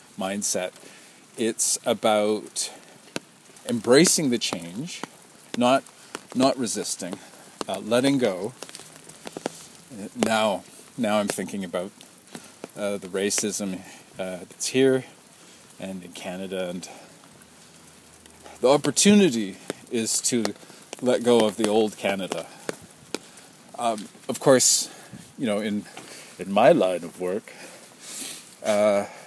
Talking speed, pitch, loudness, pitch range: 100 wpm, 105 Hz, -24 LUFS, 95-110 Hz